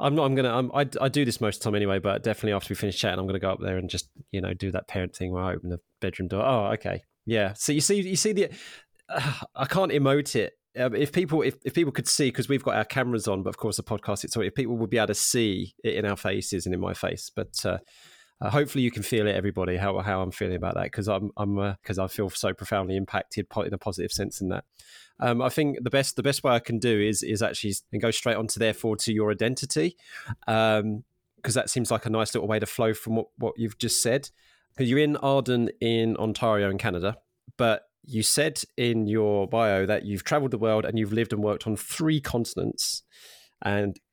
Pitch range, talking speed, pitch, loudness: 100-130 Hz, 255 wpm, 110 Hz, -27 LUFS